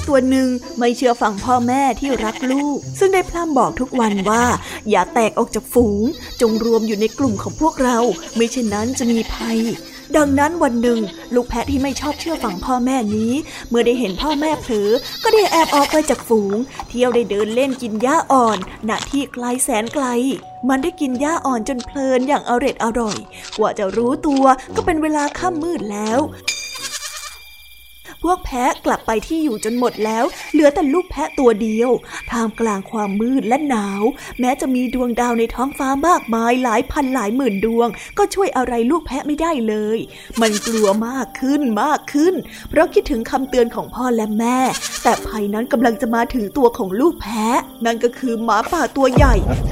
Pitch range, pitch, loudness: 225-280 Hz, 250 Hz, -18 LUFS